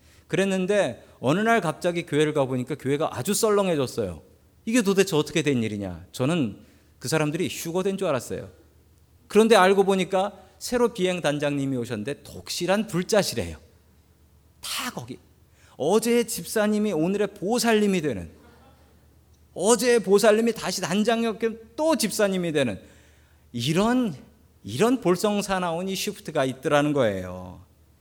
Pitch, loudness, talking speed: 165 Hz, -24 LUFS, 305 characters per minute